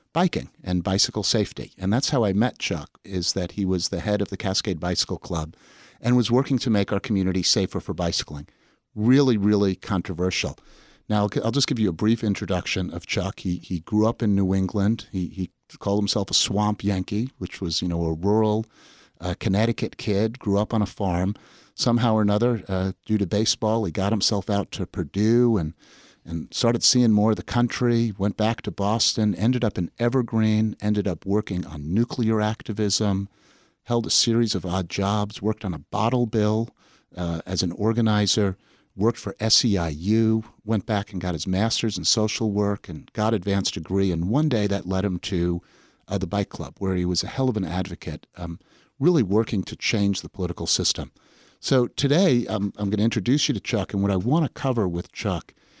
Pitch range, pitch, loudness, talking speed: 95-110 Hz, 105 Hz, -24 LUFS, 195 wpm